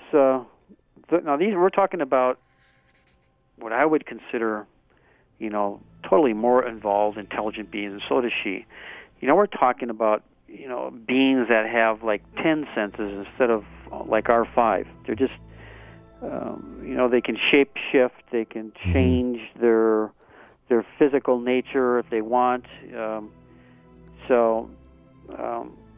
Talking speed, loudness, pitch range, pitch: 140 wpm, -23 LUFS, 105-125 Hz, 115 Hz